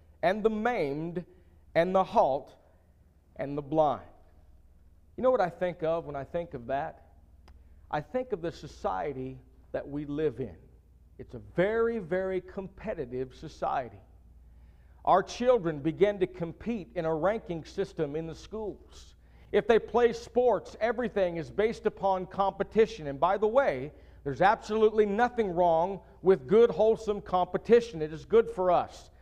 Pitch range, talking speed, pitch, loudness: 130-205 Hz, 150 wpm, 170 Hz, -29 LUFS